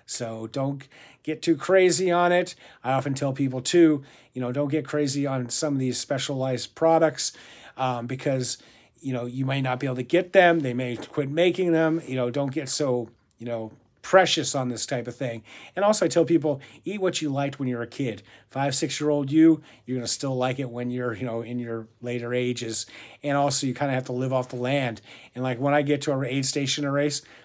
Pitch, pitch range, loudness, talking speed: 135 Hz, 125-150 Hz, -25 LUFS, 235 wpm